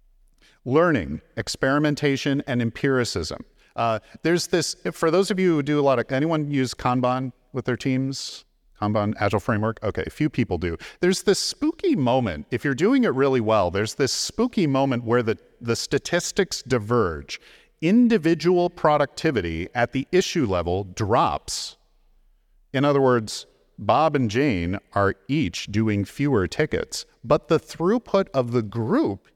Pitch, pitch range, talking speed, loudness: 135 Hz, 115-160 Hz, 150 wpm, -23 LUFS